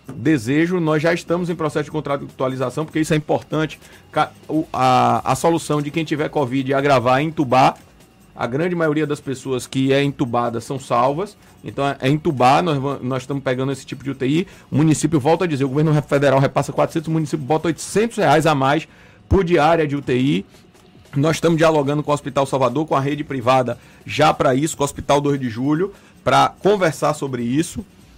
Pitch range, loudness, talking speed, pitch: 135-160 Hz, -19 LUFS, 185 wpm, 145 Hz